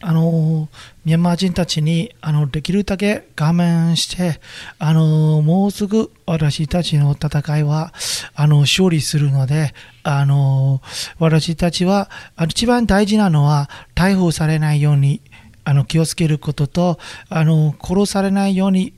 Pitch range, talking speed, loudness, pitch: 150-180 Hz, 270 characters per minute, -17 LUFS, 160 Hz